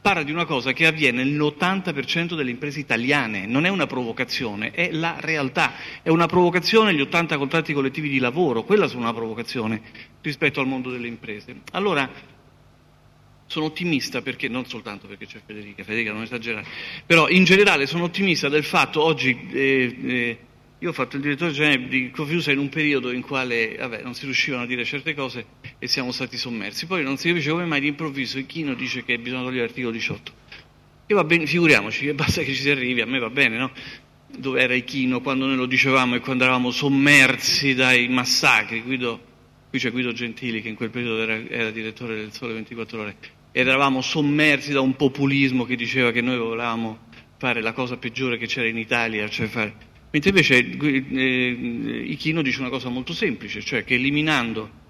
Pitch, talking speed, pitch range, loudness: 130 Hz, 185 wpm, 120-150 Hz, -21 LUFS